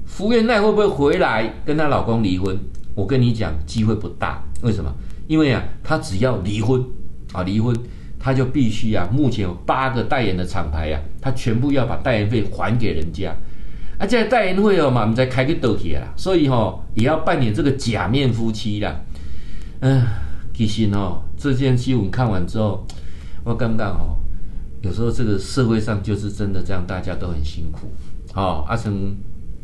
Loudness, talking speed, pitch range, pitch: -20 LUFS, 275 characters per minute, 90-130 Hz, 110 Hz